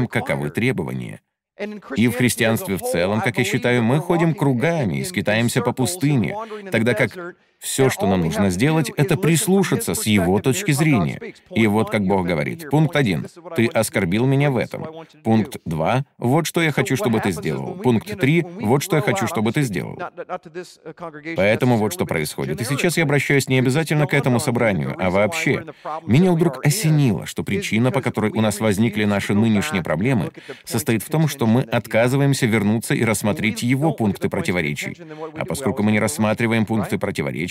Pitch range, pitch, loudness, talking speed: 110-155 Hz, 130 Hz, -20 LUFS, 170 wpm